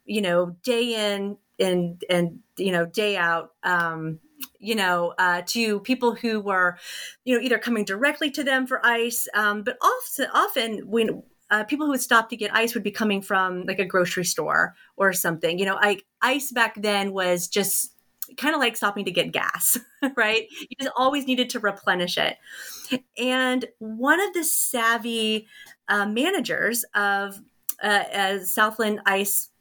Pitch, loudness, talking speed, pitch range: 215 Hz, -23 LUFS, 170 wpm, 195-250 Hz